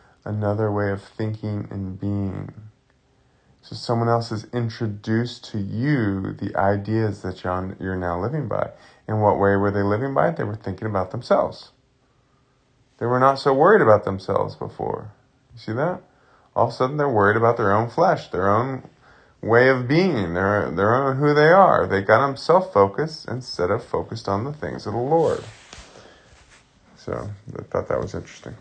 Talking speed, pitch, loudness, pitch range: 180 wpm, 110 Hz, -21 LUFS, 100-130 Hz